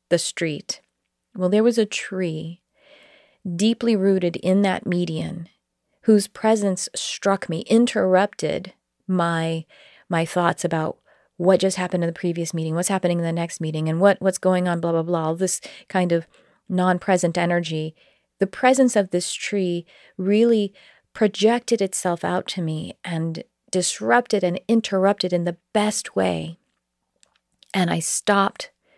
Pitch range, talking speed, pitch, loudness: 170-200 Hz, 145 wpm, 185 Hz, -22 LUFS